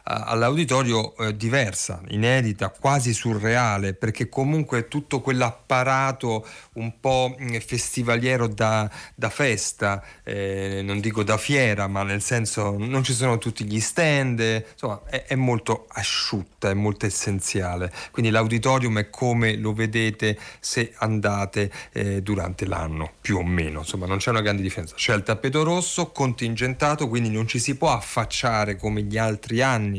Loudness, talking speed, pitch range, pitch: -23 LUFS, 145 wpm, 105-125 Hz, 110 Hz